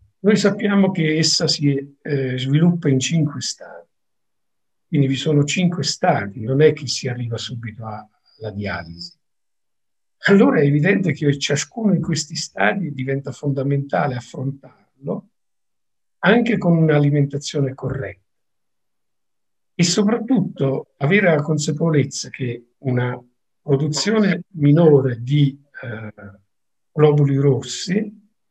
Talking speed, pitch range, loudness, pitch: 110 wpm, 130-165 Hz, -19 LUFS, 145 Hz